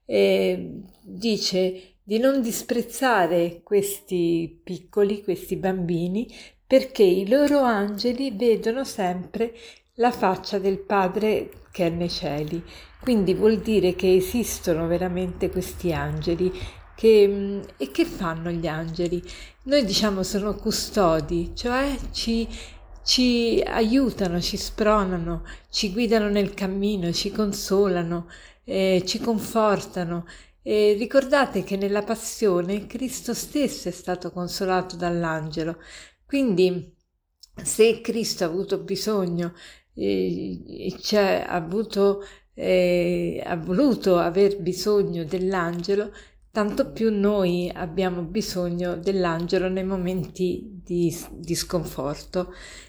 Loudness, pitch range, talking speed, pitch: -24 LUFS, 175-215 Hz, 110 wpm, 195 Hz